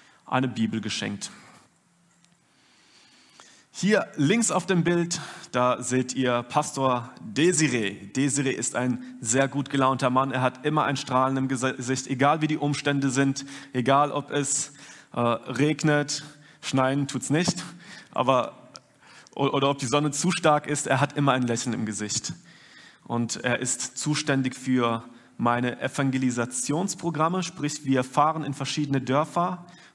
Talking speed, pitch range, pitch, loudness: 140 wpm, 130-150 Hz, 140 Hz, -25 LUFS